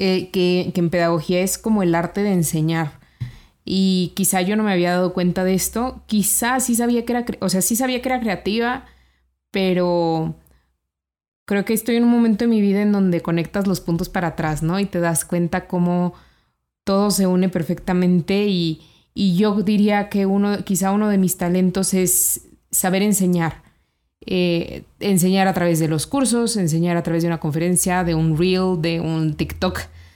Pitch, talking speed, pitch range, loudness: 185 Hz, 185 wpm, 170-200 Hz, -19 LUFS